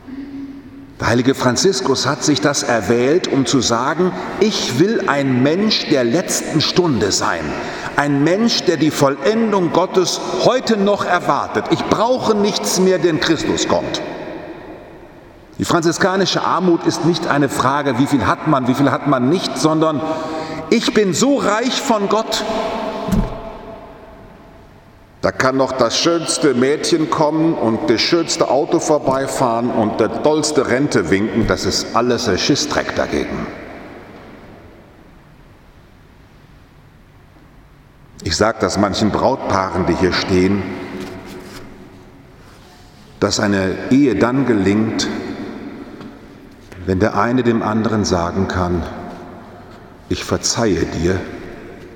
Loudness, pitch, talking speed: -16 LUFS, 145 Hz, 120 wpm